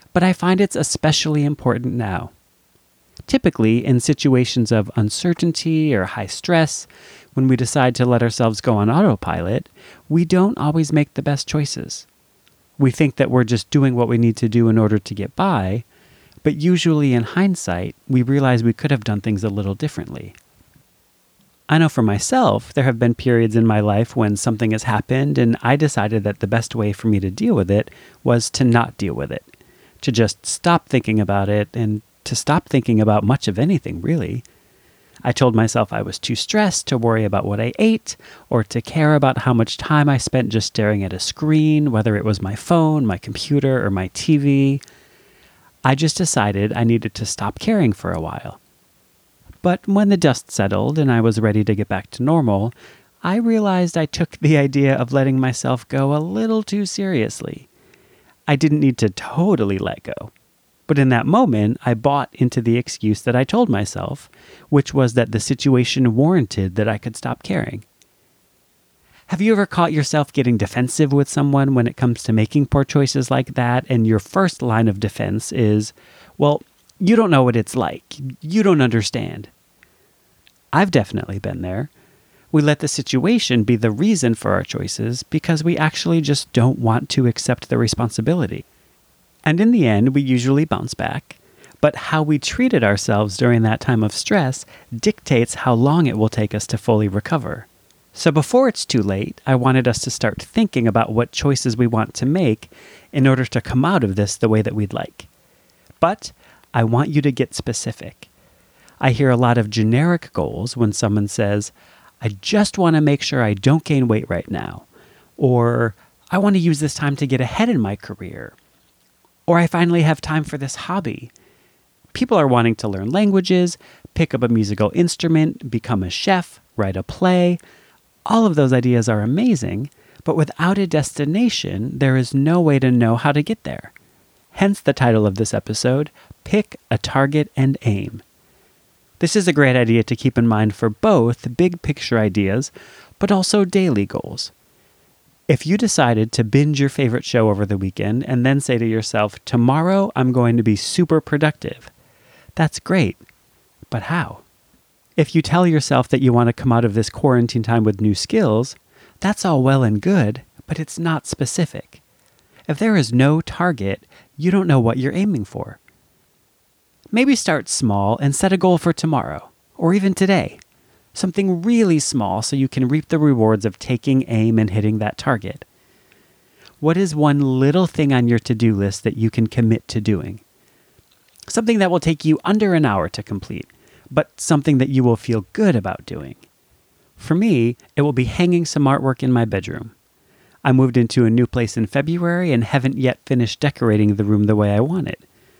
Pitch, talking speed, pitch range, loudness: 130 Hz, 185 wpm, 115-155 Hz, -18 LUFS